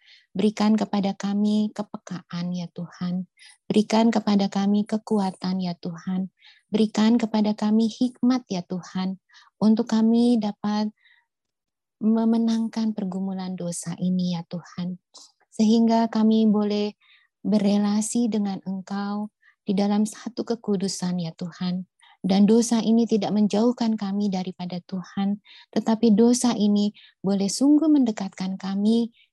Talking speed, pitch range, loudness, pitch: 110 wpm, 190-225 Hz, -24 LUFS, 210 Hz